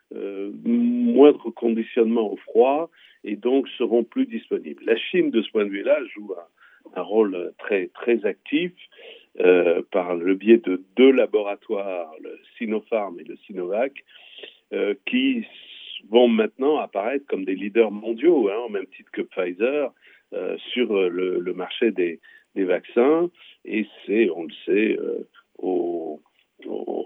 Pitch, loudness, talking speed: 295 Hz, -22 LUFS, 150 wpm